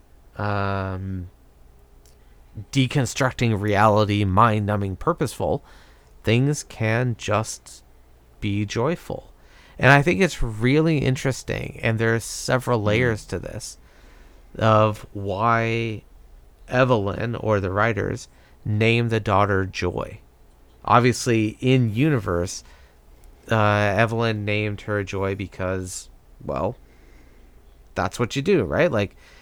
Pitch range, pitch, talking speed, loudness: 80-115 Hz, 105 Hz, 100 wpm, -22 LUFS